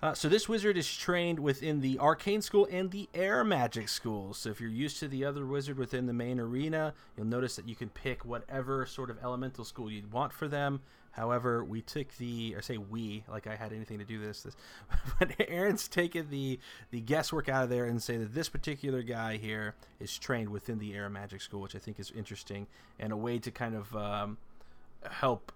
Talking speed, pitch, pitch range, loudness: 220 wpm, 125 Hz, 110-145 Hz, -35 LUFS